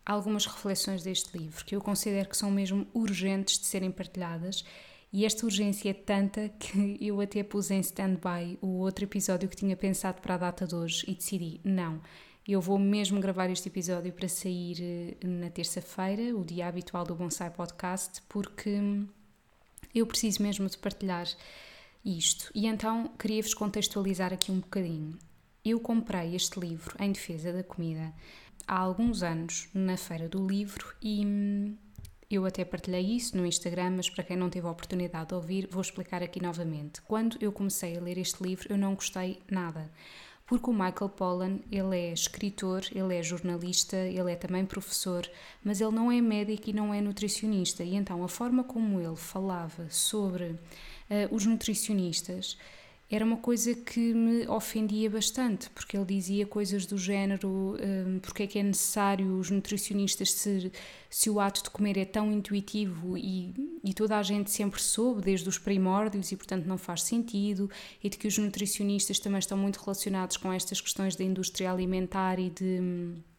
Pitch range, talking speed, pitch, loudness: 180-205 Hz, 175 wpm, 195 Hz, -31 LUFS